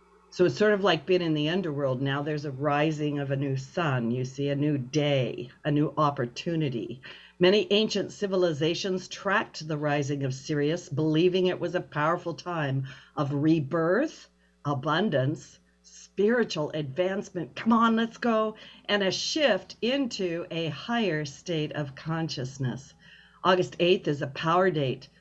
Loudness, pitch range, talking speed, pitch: -27 LUFS, 145-185 Hz, 150 wpm, 160 Hz